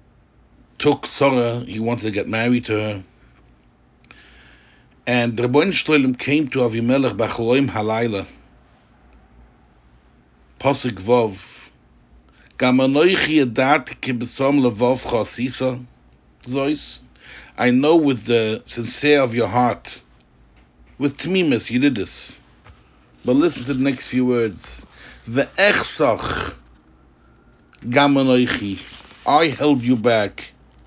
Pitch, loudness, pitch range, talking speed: 125 Hz, -19 LUFS, 105-135 Hz, 95 wpm